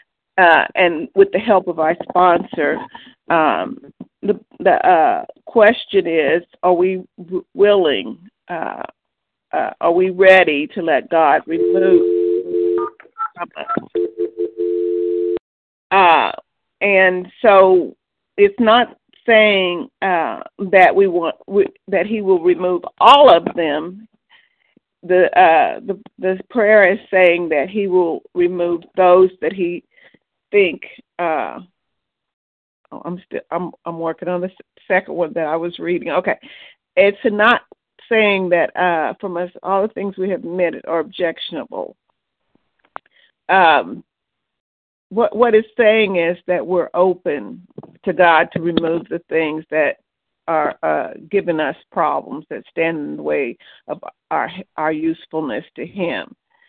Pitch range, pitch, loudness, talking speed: 165-210 Hz, 180 Hz, -16 LUFS, 130 wpm